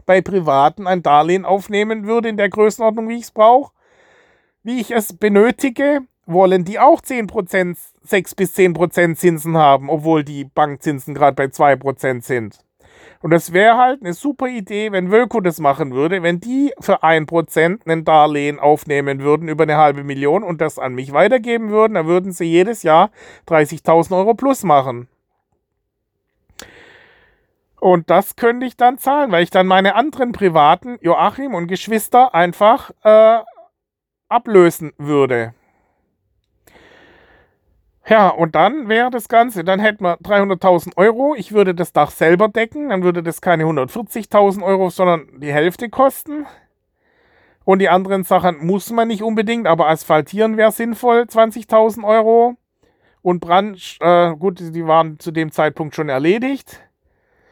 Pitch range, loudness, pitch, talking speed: 165-230 Hz, -15 LUFS, 190 Hz, 150 wpm